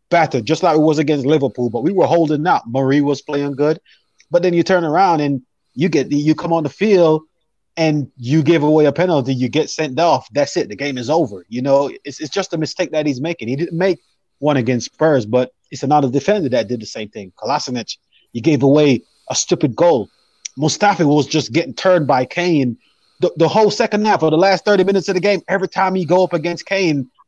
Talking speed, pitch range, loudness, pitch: 230 wpm, 140-175 Hz, -16 LUFS, 155 Hz